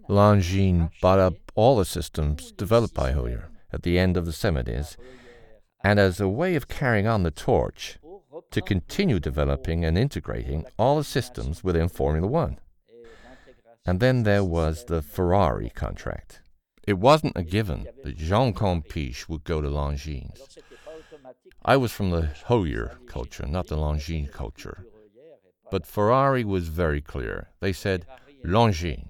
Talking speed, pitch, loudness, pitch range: 145 wpm, 90 Hz, -25 LUFS, 80-115 Hz